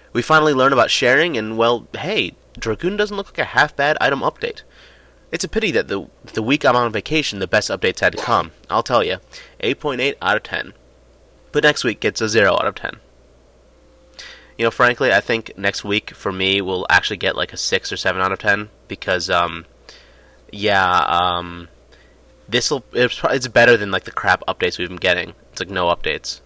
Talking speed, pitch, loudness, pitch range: 205 wpm, 100 Hz, -18 LUFS, 85-120 Hz